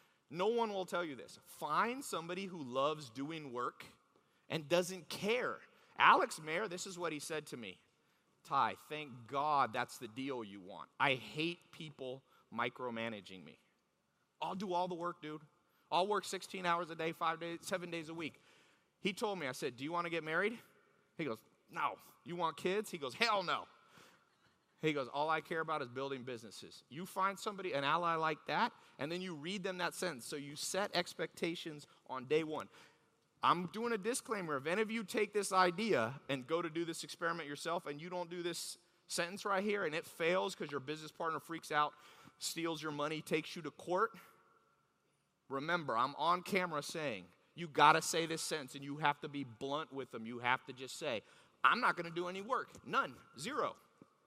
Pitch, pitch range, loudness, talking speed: 165 Hz, 145-180 Hz, -38 LUFS, 200 wpm